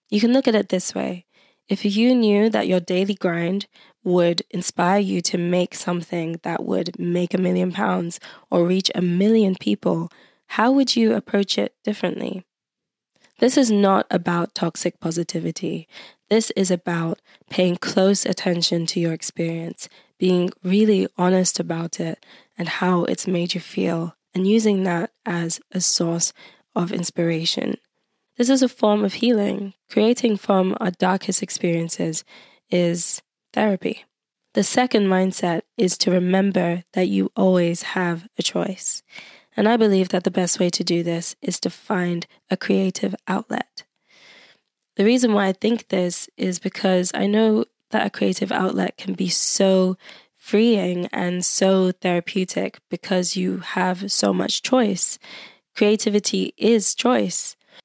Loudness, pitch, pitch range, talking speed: -21 LUFS, 185 Hz, 175-210 Hz, 145 wpm